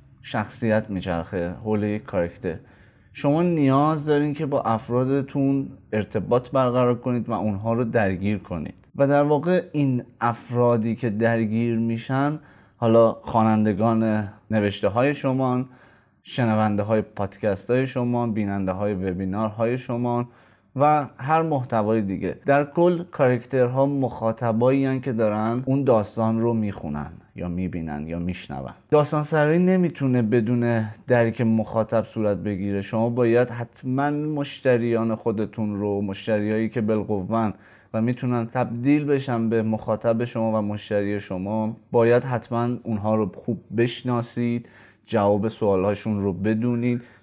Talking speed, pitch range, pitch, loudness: 125 wpm, 105-125 Hz, 115 Hz, -23 LUFS